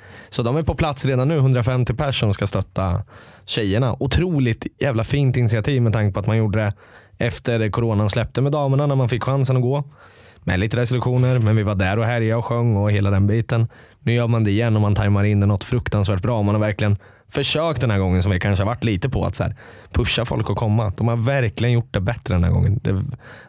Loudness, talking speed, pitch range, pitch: -20 LUFS, 240 wpm, 105-125 Hz, 115 Hz